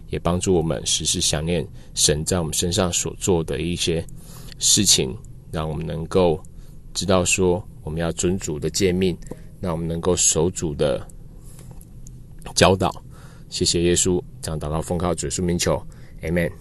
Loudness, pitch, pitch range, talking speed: -21 LUFS, 85 Hz, 80-95 Hz, 230 characters per minute